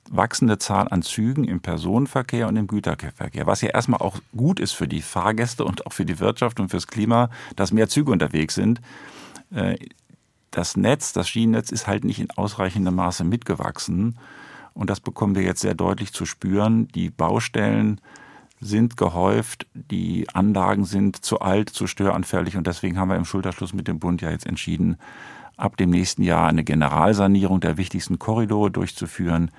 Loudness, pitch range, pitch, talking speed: -22 LUFS, 90-110 Hz, 100 Hz, 170 wpm